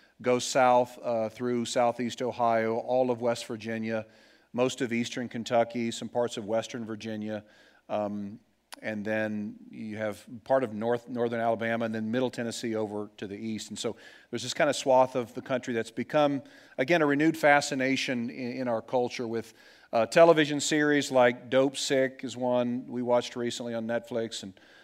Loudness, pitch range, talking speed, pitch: -28 LUFS, 115-130 Hz, 175 wpm, 120 Hz